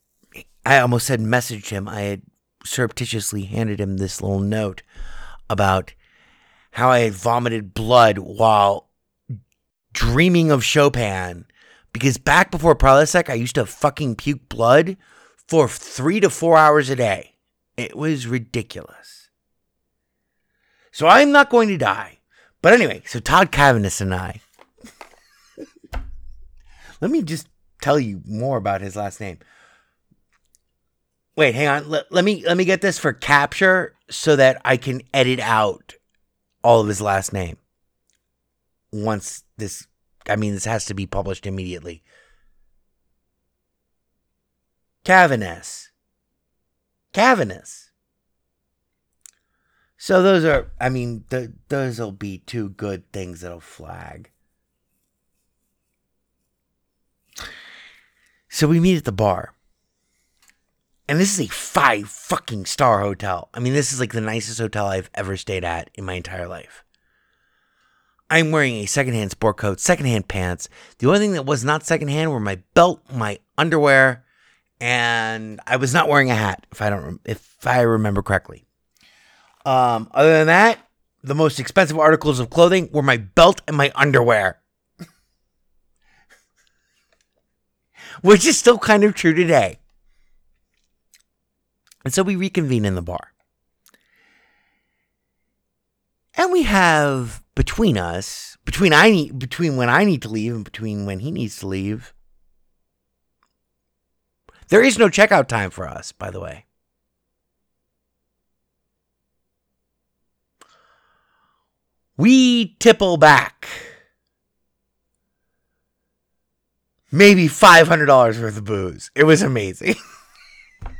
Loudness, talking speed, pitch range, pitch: -17 LUFS, 125 wpm, 90-150 Hz, 115 Hz